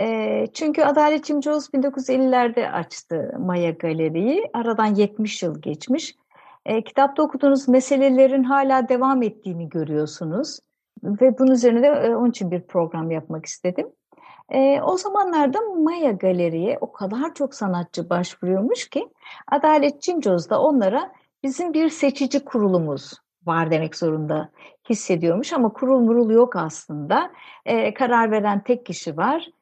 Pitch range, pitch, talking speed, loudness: 175-280 Hz, 240 Hz, 120 wpm, -21 LUFS